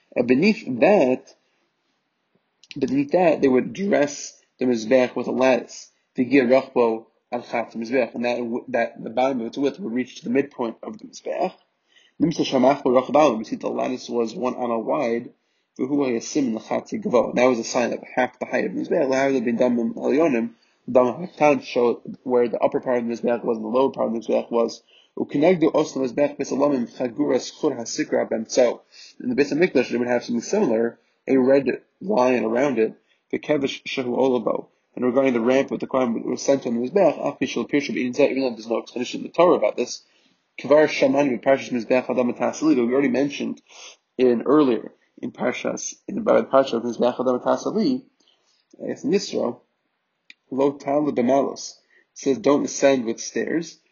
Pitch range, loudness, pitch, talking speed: 120-140 Hz, -22 LUFS, 130 Hz, 180 wpm